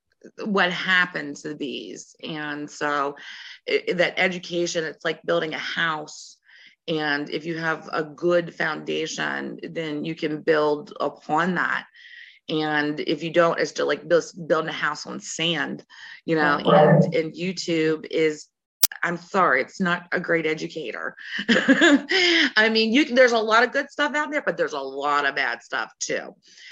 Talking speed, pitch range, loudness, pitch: 165 wpm, 150-215 Hz, -23 LUFS, 165 Hz